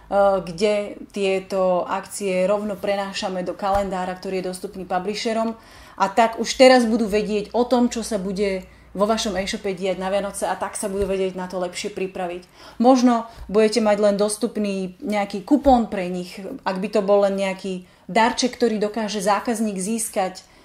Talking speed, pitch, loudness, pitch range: 165 wpm, 200 Hz, -22 LUFS, 190-225 Hz